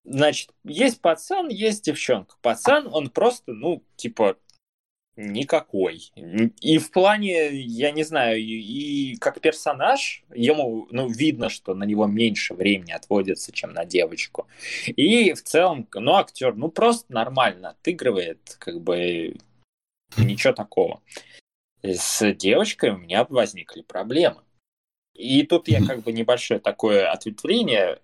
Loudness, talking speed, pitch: -22 LUFS, 130 wpm, 155 Hz